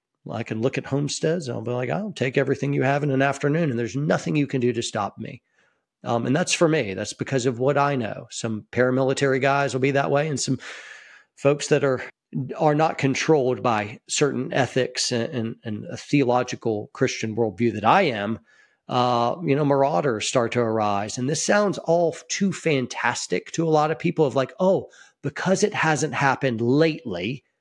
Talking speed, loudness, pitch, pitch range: 200 wpm, -23 LUFS, 135 Hz, 120-150 Hz